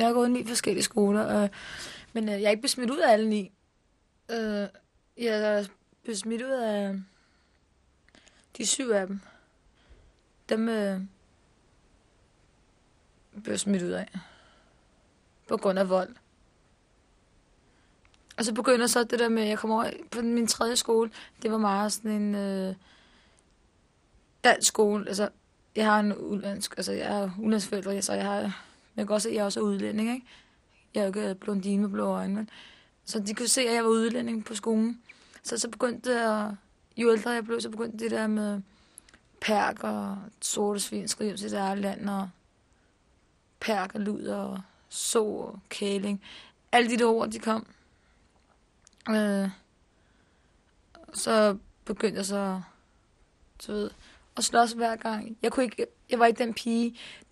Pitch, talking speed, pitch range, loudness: 215 Hz, 165 wpm, 200-230 Hz, -28 LUFS